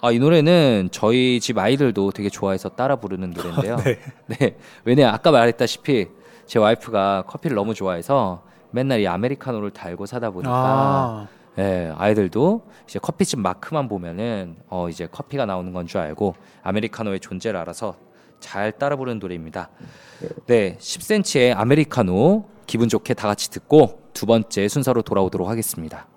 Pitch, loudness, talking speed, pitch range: 110 Hz, -21 LUFS, 355 characters per minute, 95-130 Hz